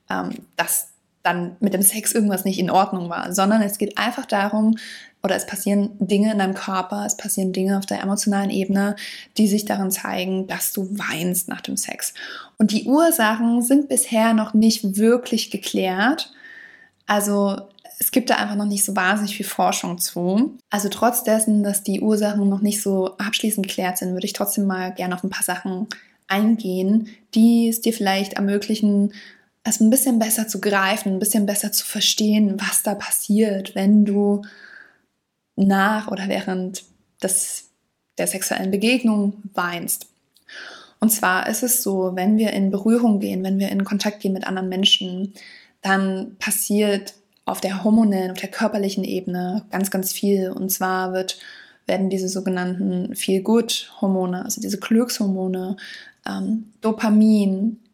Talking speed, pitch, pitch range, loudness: 160 wpm, 205 Hz, 195-220 Hz, -20 LUFS